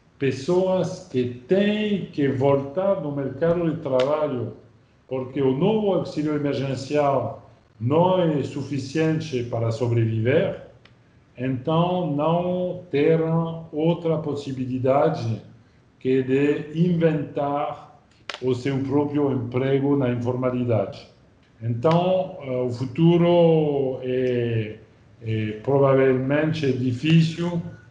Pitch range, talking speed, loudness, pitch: 130-160 Hz, 90 wpm, -23 LUFS, 140 Hz